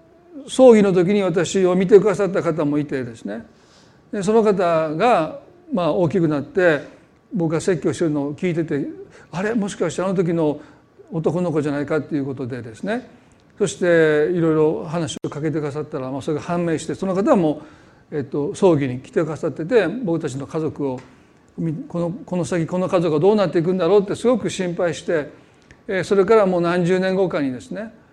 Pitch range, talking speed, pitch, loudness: 150-195 Hz, 360 characters per minute, 175 Hz, -20 LUFS